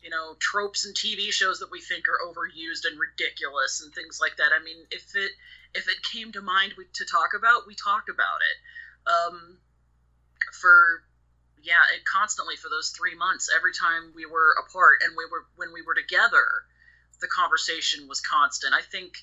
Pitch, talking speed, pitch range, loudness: 195 Hz, 185 wpm, 160-260 Hz, -23 LUFS